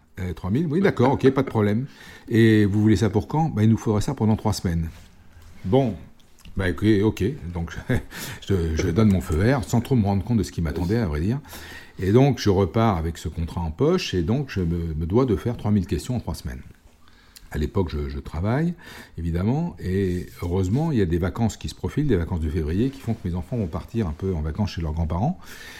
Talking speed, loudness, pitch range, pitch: 235 wpm, -23 LUFS, 85-115 Hz, 95 Hz